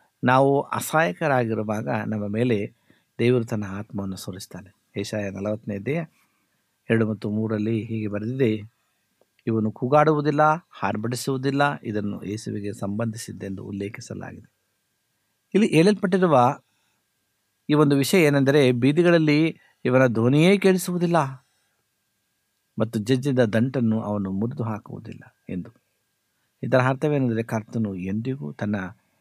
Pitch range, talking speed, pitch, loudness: 105-135 Hz, 90 wpm, 115 Hz, -23 LUFS